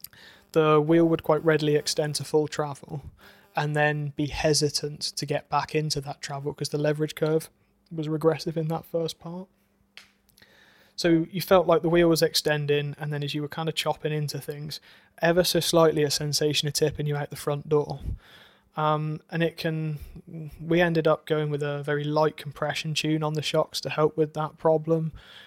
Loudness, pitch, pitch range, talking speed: -25 LUFS, 155 Hz, 150-160 Hz, 190 wpm